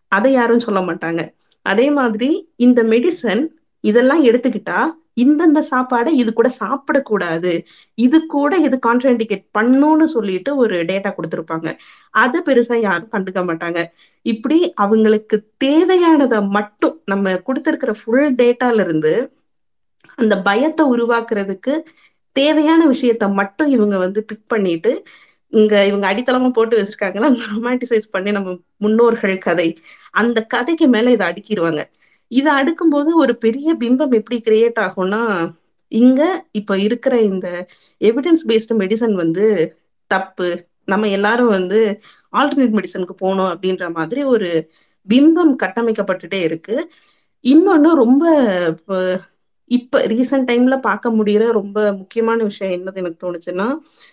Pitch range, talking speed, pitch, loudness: 195-265 Hz, 120 wpm, 225 Hz, -16 LUFS